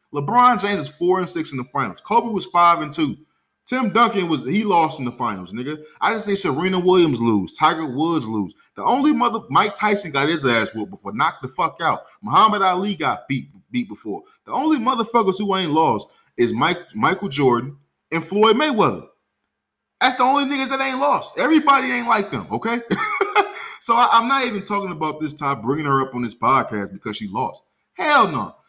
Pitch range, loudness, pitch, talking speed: 150-235 Hz, -19 LUFS, 190 Hz, 200 wpm